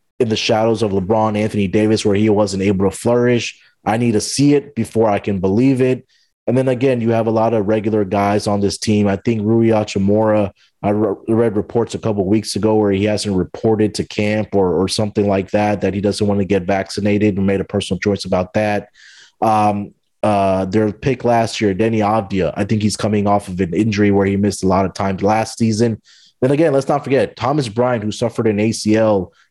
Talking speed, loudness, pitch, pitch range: 225 wpm, -17 LUFS, 105 Hz, 100-115 Hz